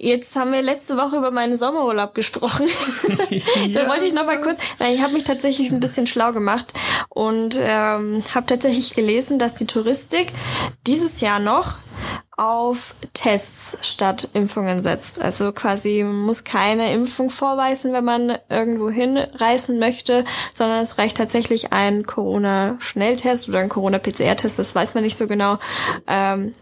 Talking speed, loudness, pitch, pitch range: 150 wpm, -19 LUFS, 235 Hz, 210-260 Hz